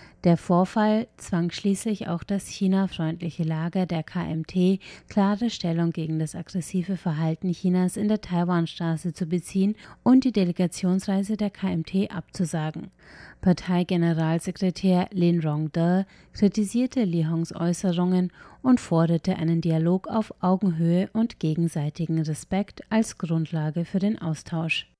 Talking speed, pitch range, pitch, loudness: 120 wpm, 165-195 Hz, 180 Hz, -25 LUFS